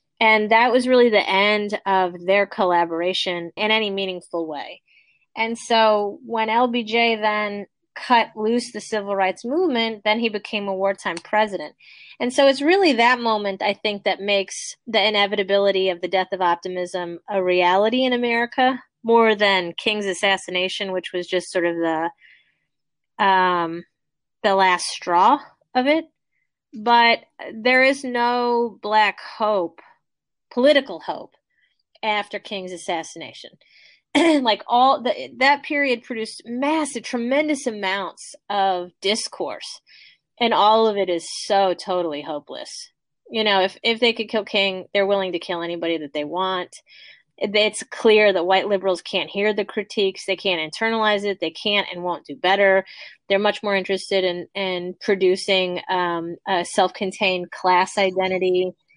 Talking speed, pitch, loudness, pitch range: 150 wpm, 200 Hz, -20 LUFS, 185-230 Hz